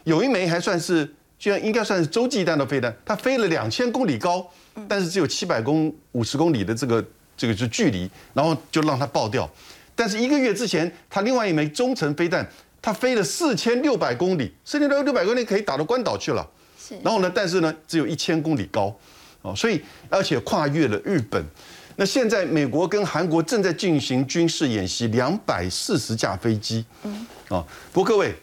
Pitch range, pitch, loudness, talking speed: 145-215 Hz, 170 Hz, -23 LUFS, 305 characters per minute